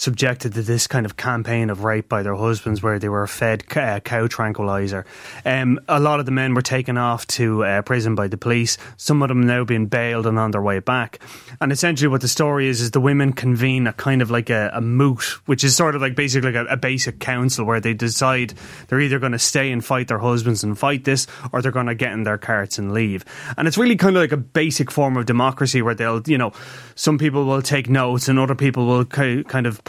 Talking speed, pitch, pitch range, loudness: 245 wpm, 125 Hz, 115-135 Hz, -19 LUFS